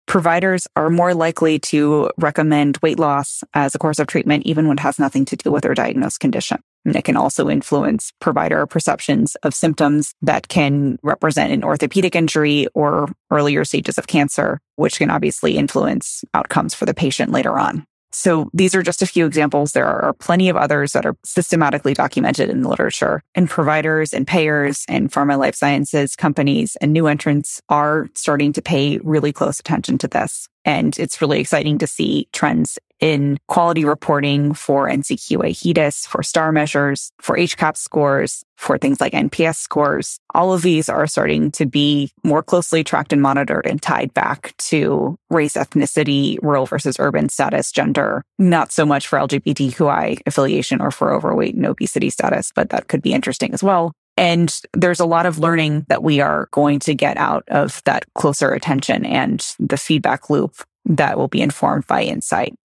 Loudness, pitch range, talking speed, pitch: -17 LUFS, 145-165 Hz, 180 wpm, 150 Hz